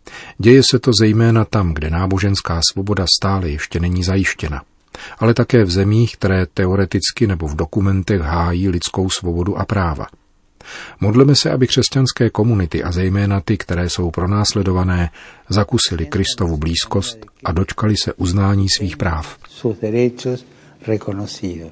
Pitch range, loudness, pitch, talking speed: 90-110 Hz, -16 LUFS, 100 Hz, 125 wpm